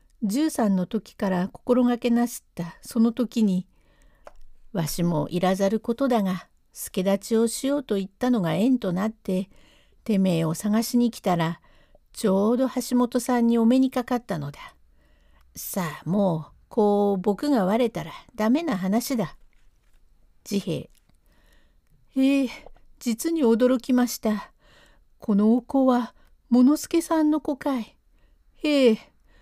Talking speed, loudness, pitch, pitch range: 240 characters per minute, -24 LUFS, 225 Hz, 190-250 Hz